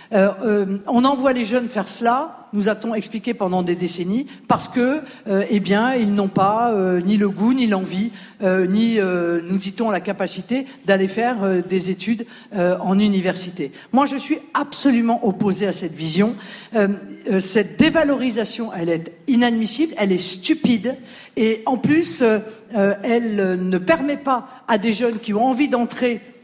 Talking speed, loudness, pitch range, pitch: 175 wpm, -20 LUFS, 195-245 Hz, 215 Hz